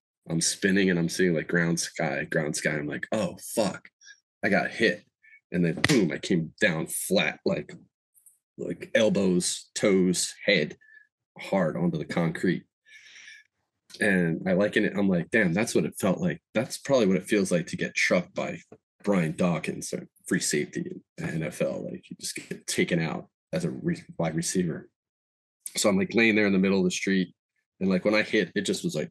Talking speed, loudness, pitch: 190 wpm, -26 LUFS, 95 Hz